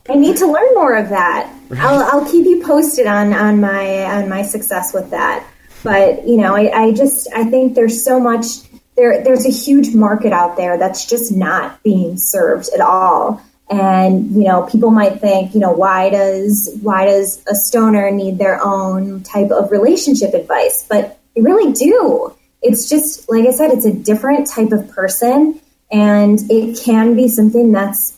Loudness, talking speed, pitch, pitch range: -12 LUFS, 185 wpm, 215 Hz, 195-255 Hz